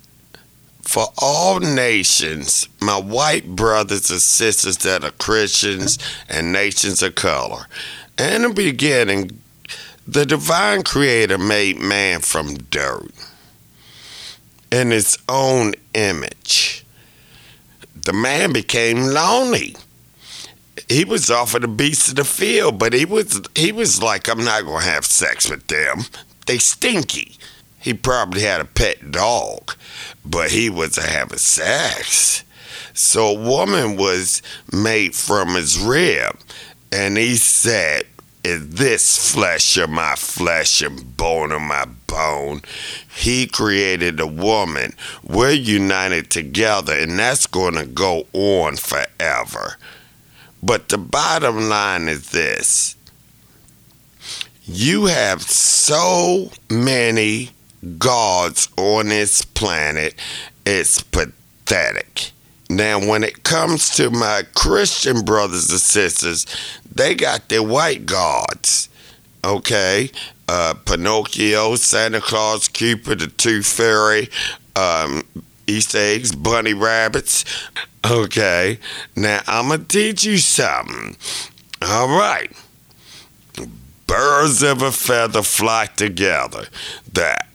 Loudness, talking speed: -16 LUFS, 115 wpm